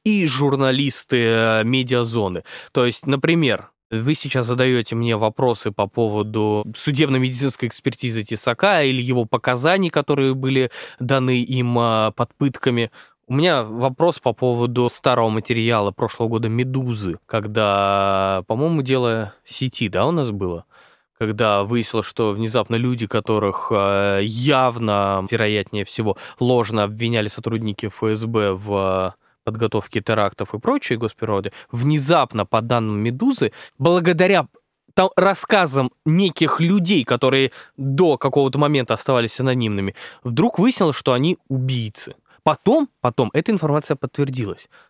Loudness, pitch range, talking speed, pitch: -19 LUFS, 110-140 Hz, 115 wpm, 120 Hz